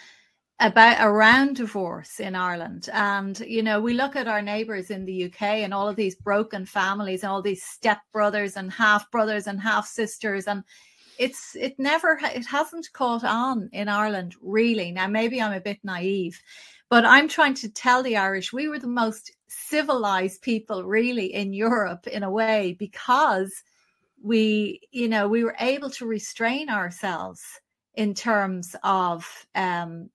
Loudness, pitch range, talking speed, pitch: -23 LUFS, 195-235 Hz, 165 wpm, 215 Hz